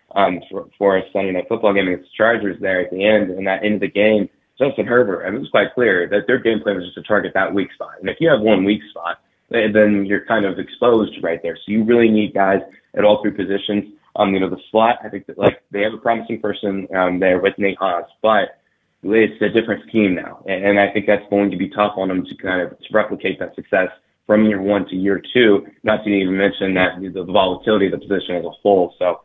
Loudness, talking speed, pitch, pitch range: -18 LUFS, 250 wpm, 100 Hz, 95-105 Hz